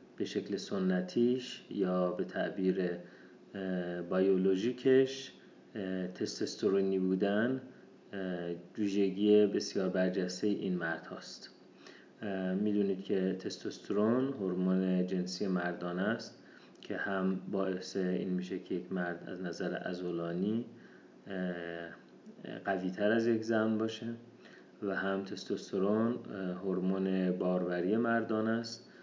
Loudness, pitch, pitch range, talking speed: -34 LUFS, 95 Hz, 90-105 Hz, 95 wpm